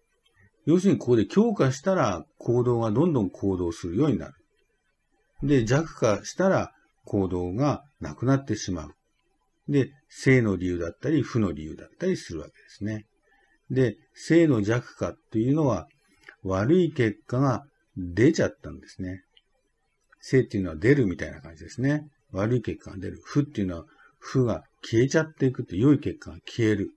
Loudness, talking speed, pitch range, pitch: -25 LUFS, 325 characters per minute, 95-145 Hz, 120 Hz